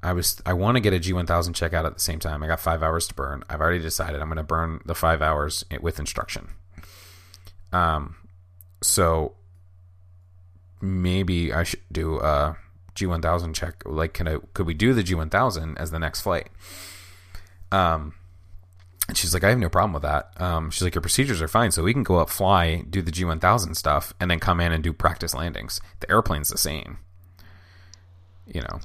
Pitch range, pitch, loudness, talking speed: 80-90 Hz, 90 Hz, -24 LUFS, 195 wpm